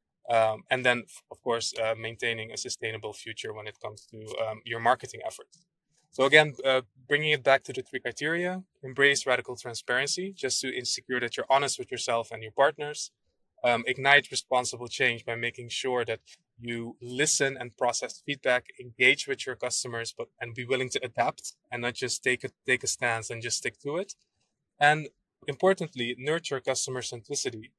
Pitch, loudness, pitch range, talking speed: 125 Hz, -28 LUFS, 115-145 Hz, 180 wpm